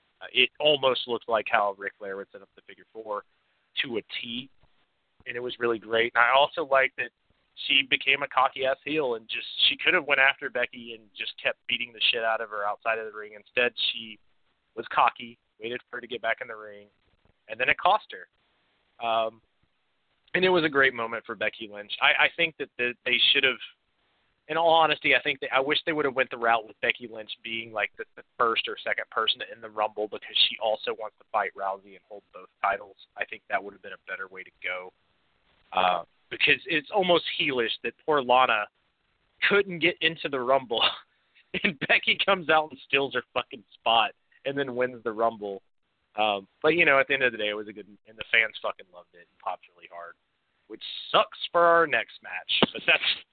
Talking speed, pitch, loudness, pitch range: 225 wpm, 115 Hz, -25 LUFS, 105-140 Hz